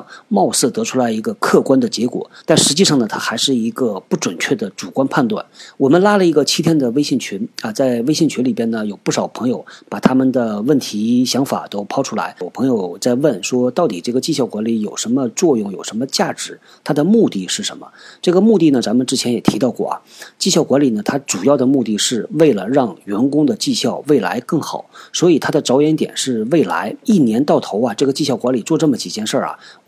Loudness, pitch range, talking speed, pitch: -16 LUFS, 120-170 Hz, 330 characters per minute, 130 Hz